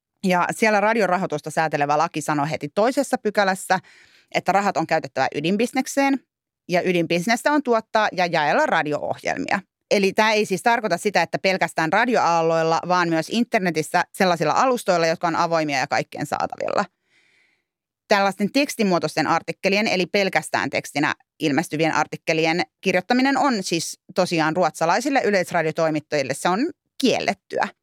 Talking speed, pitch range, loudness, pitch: 125 wpm, 160-210 Hz, -21 LUFS, 180 Hz